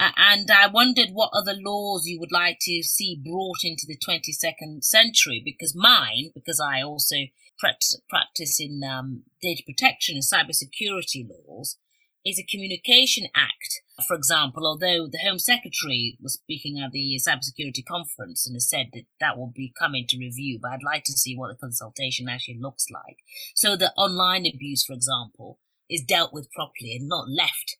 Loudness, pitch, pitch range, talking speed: -22 LUFS, 155 Hz, 135-185 Hz, 175 wpm